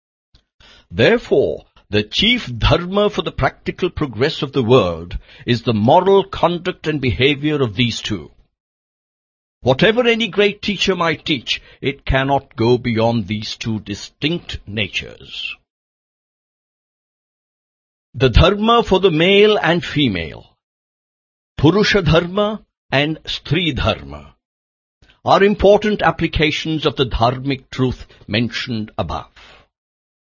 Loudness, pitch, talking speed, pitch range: -17 LUFS, 135 Hz, 110 wpm, 110-175 Hz